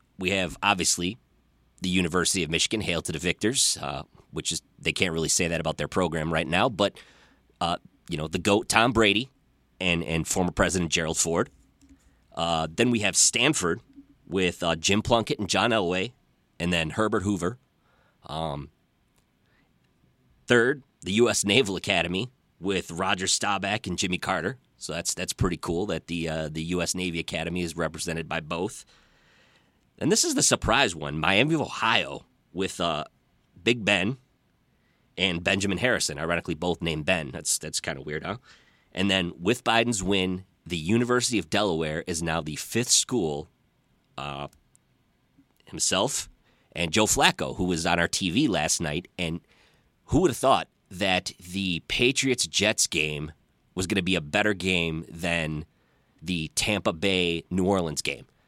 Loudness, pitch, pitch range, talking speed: -25 LUFS, 90 Hz, 85-100 Hz, 160 wpm